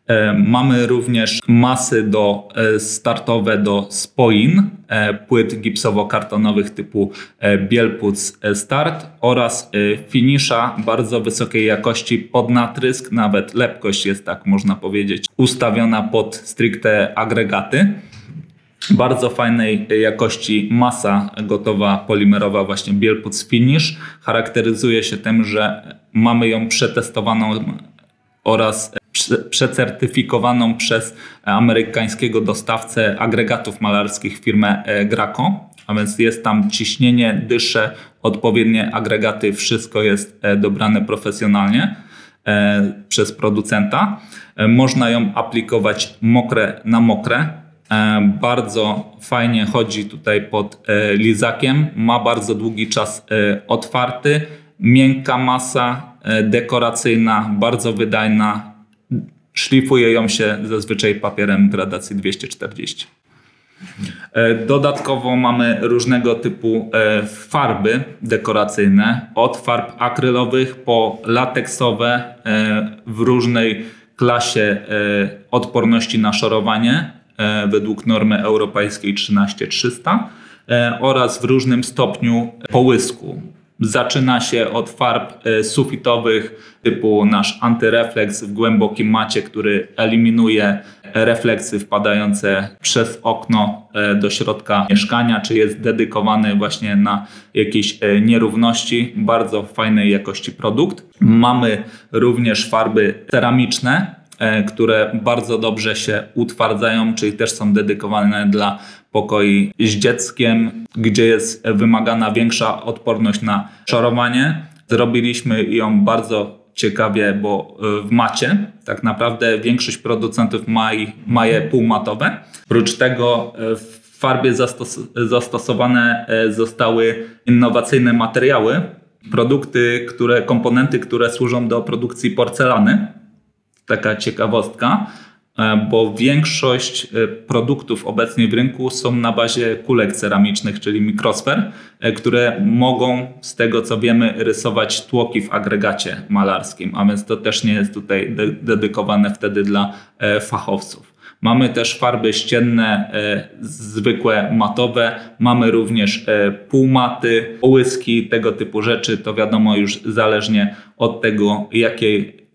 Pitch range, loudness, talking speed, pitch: 105-120 Hz, -16 LUFS, 100 wpm, 115 Hz